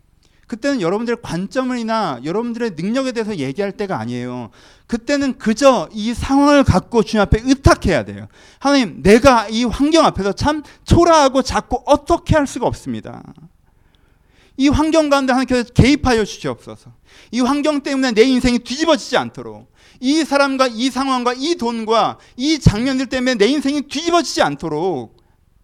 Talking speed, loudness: 350 characters per minute, -16 LUFS